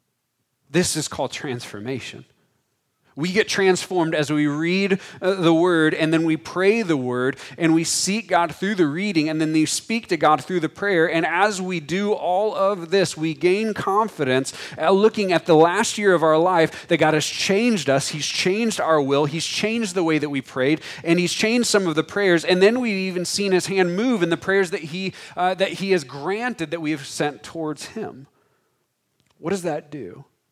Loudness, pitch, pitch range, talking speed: -21 LUFS, 170 Hz, 155-195 Hz, 205 wpm